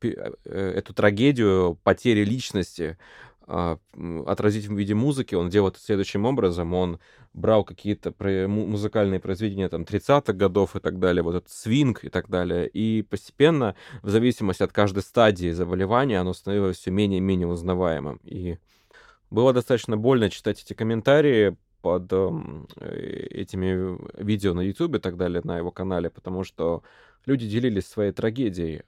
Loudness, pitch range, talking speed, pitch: -24 LUFS, 90-110 Hz, 145 wpm, 100 Hz